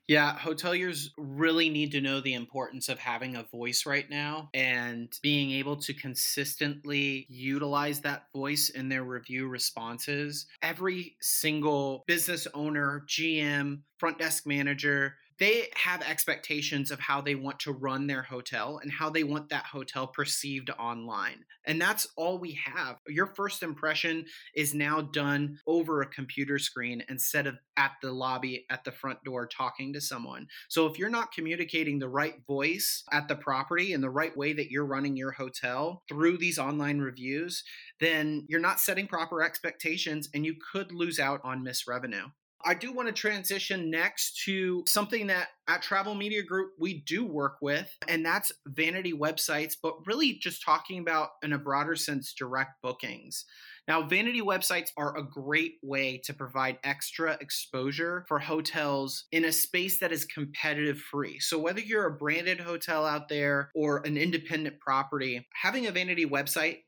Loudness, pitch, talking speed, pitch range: -30 LUFS, 150 Hz, 165 wpm, 140-165 Hz